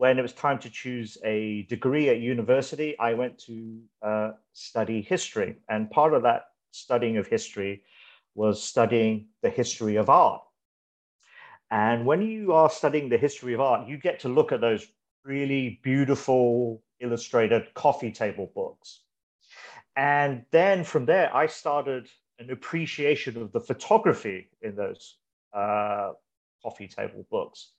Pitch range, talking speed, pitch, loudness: 110-145 Hz, 145 wpm, 125 Hz, -26 LUFS